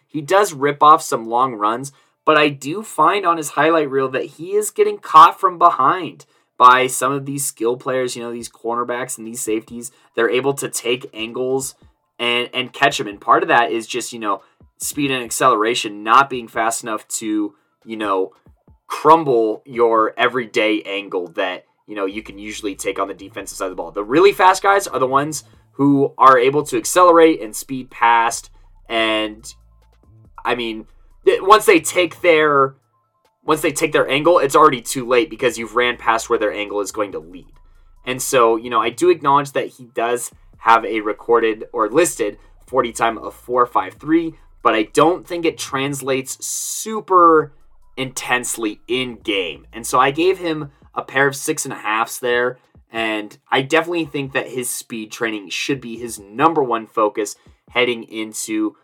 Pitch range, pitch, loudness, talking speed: 115-155 Hz, 125 Hz, -17 LUFS, 185 wpm